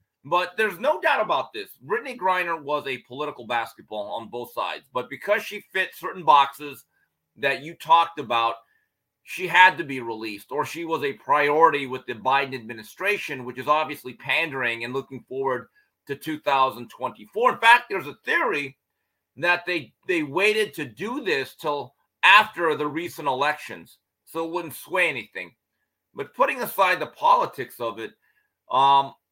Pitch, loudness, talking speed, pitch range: 160 Hz, -23 LUFS, 160 wpm, 135-205 Hz